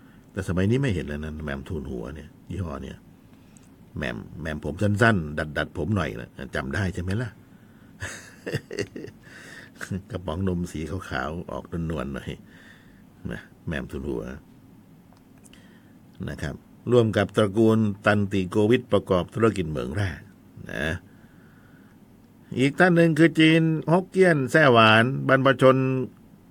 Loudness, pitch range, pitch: -23 LUFS, 90-130 Hz, 105 Hz